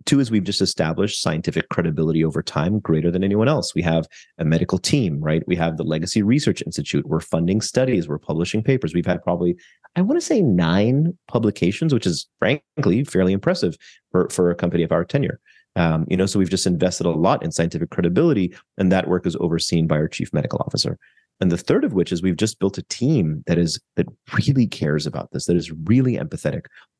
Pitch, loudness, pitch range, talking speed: 90 Hz, -21 LUFS, 80-105 Hz, 215 wpm